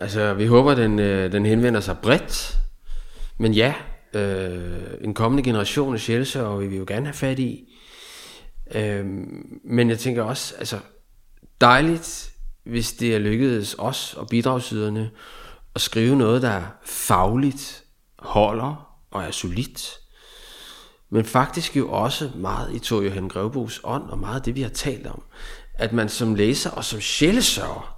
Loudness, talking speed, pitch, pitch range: -22 LUFS, 155 wpm, 115 Hz, 105-125 Hz